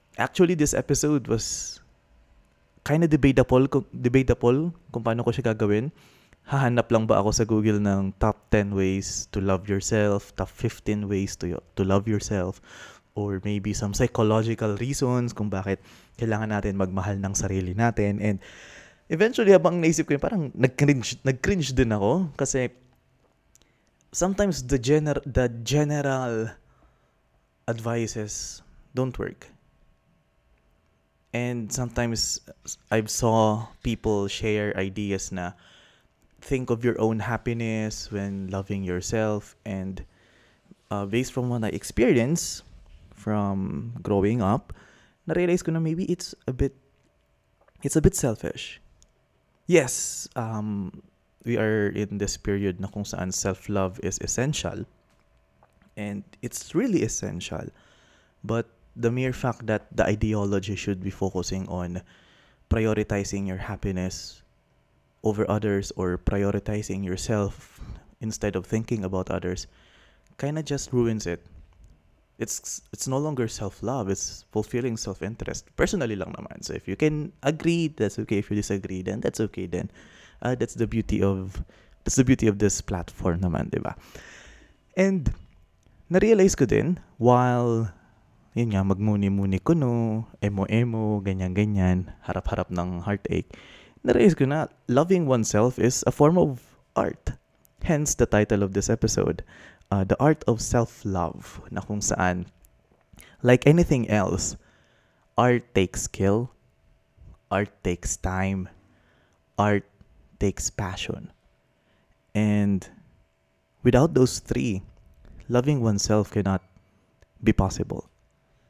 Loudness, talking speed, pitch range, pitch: -25 LUFS, 125 wpm, 95-120 Hz, 105 Hz